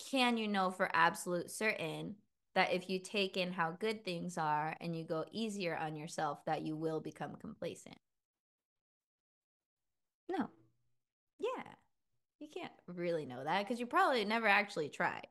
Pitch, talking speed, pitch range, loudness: 180 Hz, 155 wpm, 160-215 Hz, -37 LUFS